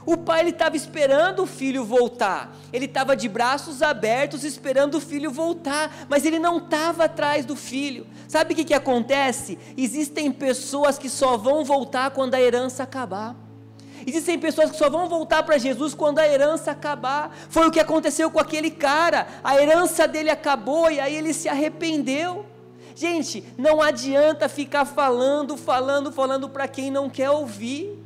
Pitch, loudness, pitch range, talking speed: 290 Hz, -22 LUFS, 270-315 Hz, 165 wpm